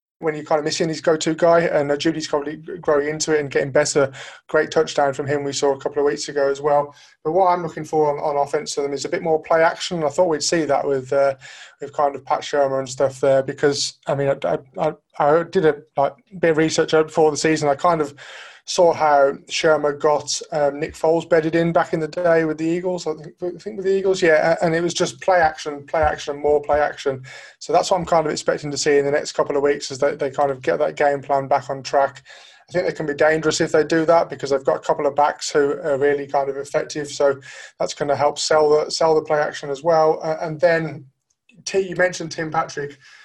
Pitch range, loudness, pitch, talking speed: 145-165 Hz, -20 LUFS, 150 Hz, 255 wpm